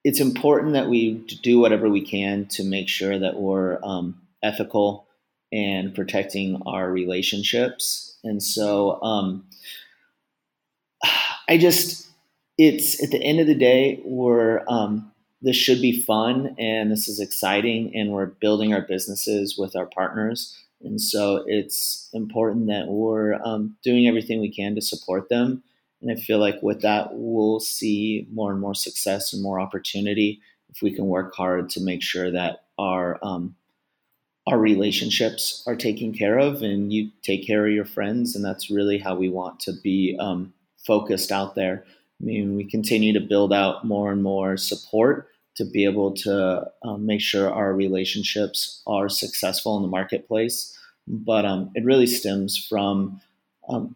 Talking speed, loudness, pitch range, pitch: 160 wpm, -22 LUFS, 95-110 Hz, 105 Hz